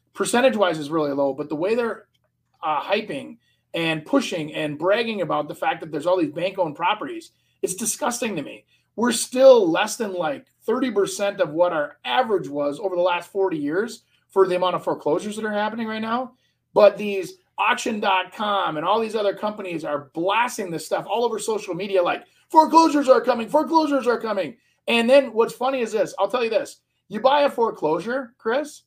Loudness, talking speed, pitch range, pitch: -22 LUFS, 195 wpm, 185-260 Hz, 220 Hz